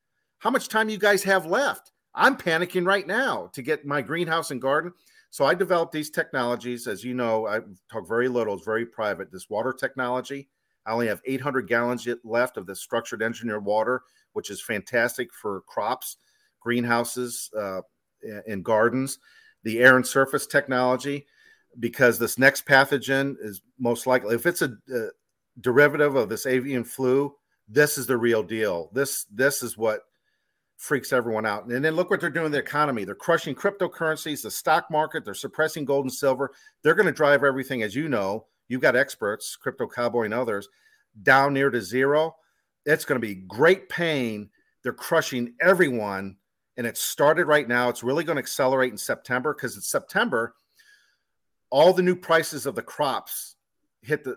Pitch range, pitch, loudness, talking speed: 120-160 Hz, 135 Hz, -24 LUFS, 175 wpm